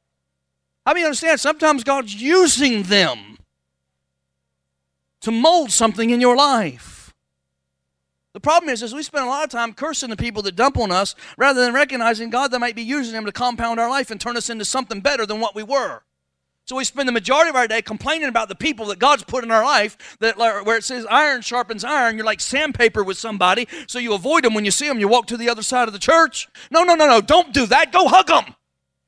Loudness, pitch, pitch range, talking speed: -18 LUFS, 235 Hz, 205-275 Hz, 225 wpm